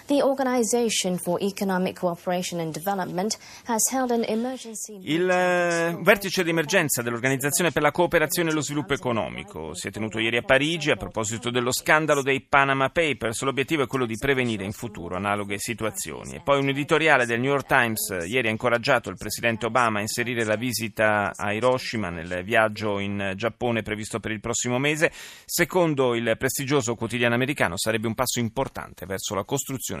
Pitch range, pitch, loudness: 110-170 Hz, 130 Hz, -24 LUFS